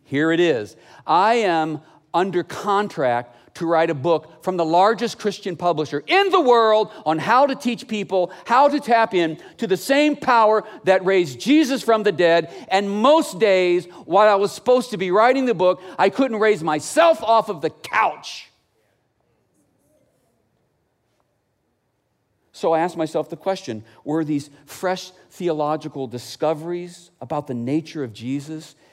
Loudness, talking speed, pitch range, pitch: -20 LUFS, 155 wpm, 155-215 Hz, 180 Hz